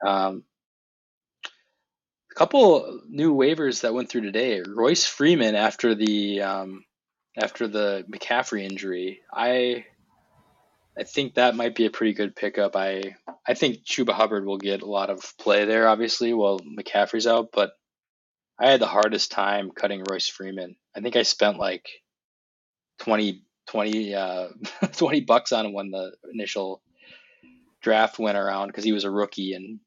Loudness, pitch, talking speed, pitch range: -24 LUFS, 100 Hz, 155 wpm, 95-110 Hz